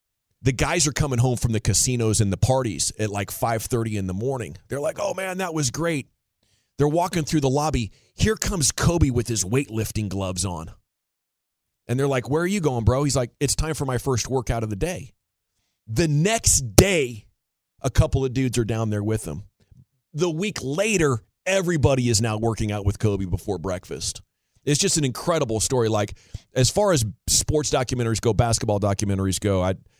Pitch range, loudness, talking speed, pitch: 105-140 Hz, -23 LUFS, 190 wpm, 120 Hz